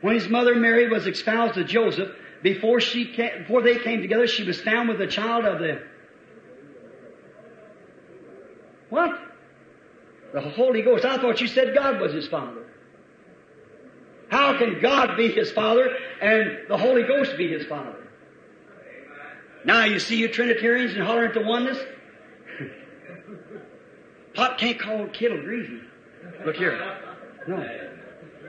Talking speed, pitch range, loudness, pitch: 135 wpm, 220-250 Hz, -22 LUFS, 235 Hz